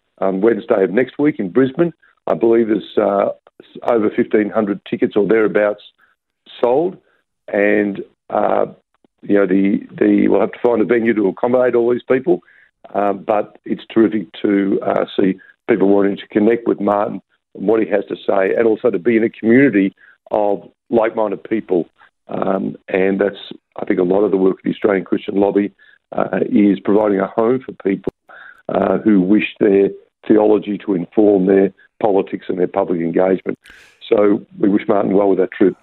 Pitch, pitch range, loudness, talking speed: 105 Hz, 100-115 Hz, -16 LUFS, 180 wpm